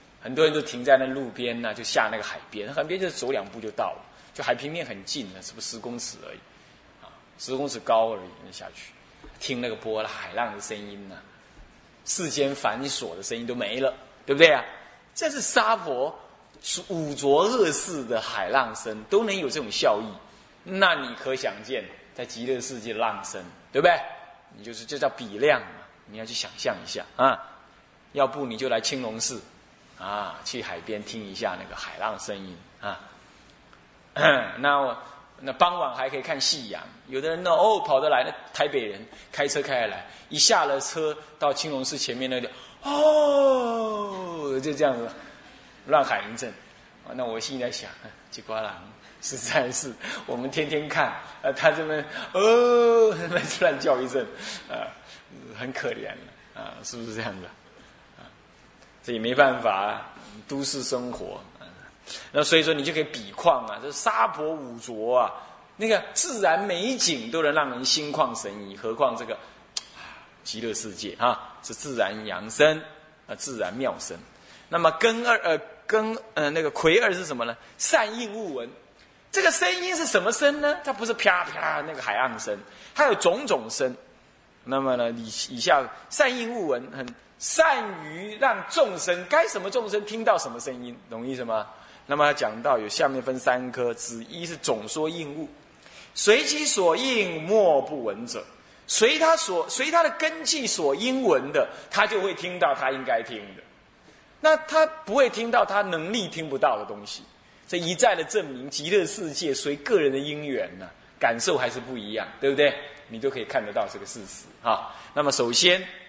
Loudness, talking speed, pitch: -25 LUFS, 250 characters per minute, 155 Hz